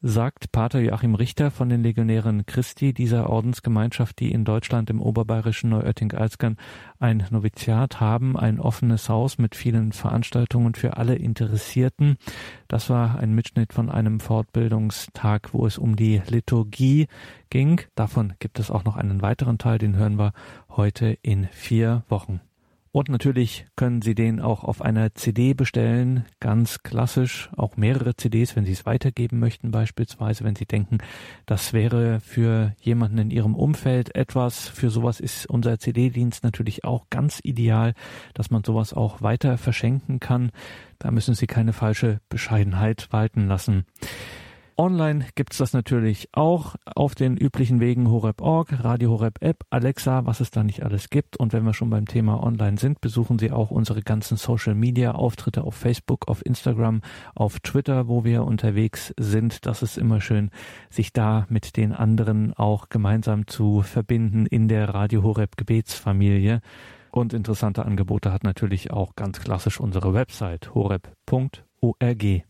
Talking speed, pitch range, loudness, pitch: 155 wpm, 110-125 Hz, -23 LUFS, 115 Hz